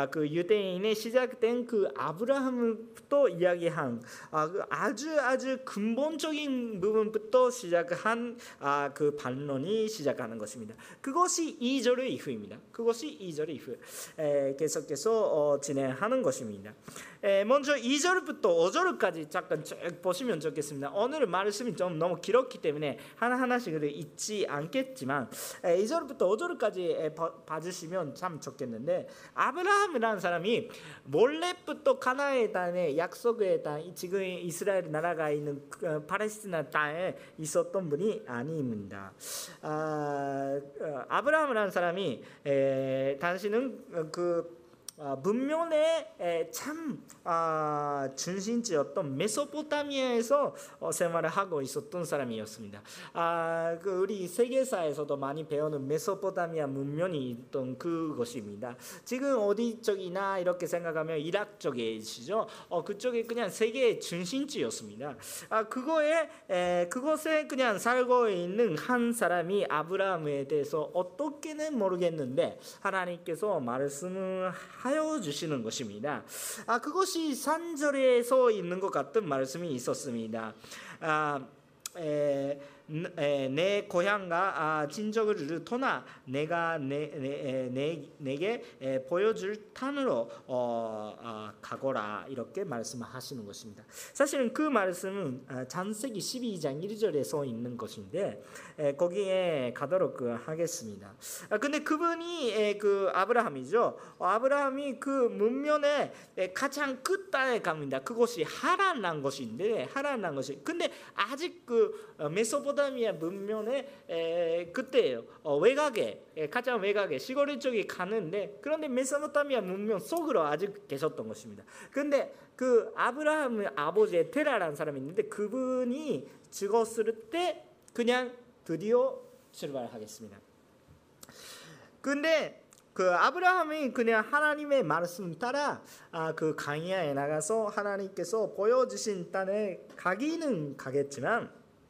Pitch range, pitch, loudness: 155-260 Hz, 200 Hz, -31 LUFS